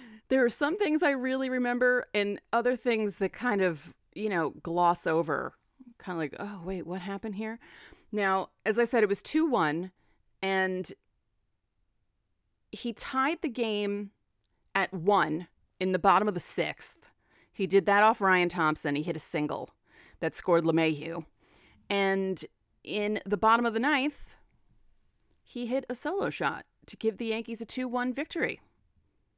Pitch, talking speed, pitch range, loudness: 205 Hz, 160 wpm, 175-240 Hz, -29 LUFS